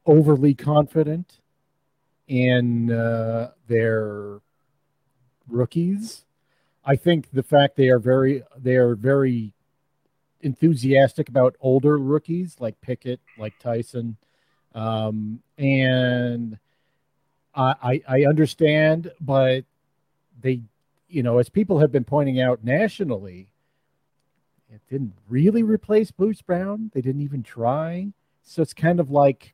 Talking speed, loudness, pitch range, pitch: 115 wpm, -21 LUFS, 120-155 Hz, 135 Hz